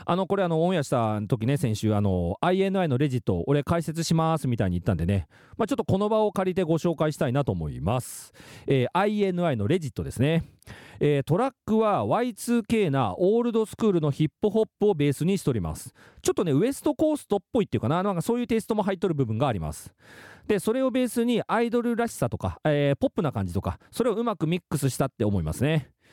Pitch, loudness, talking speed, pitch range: 165 Hz, -26 LUFS, 455 characters per minute, 135-215 Hz